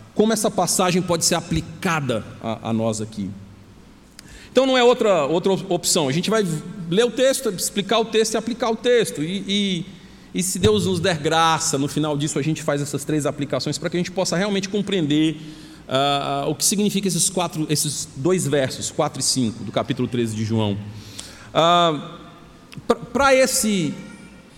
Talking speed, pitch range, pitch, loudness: 180 wpm, 140-195 Hz, 170 Hz, -20 LUFS